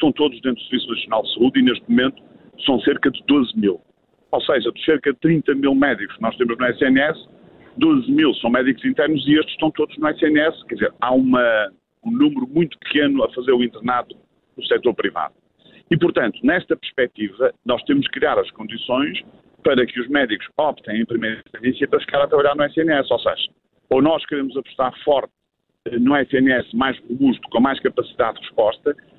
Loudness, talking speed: -19 LUFS, 195 wpm